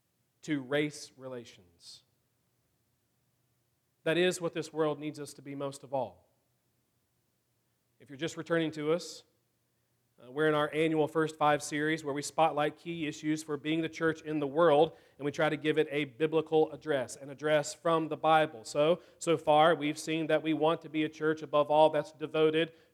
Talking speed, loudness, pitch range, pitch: 185 wpm, -31 LUFS, 145-160 Hz, 155 Hz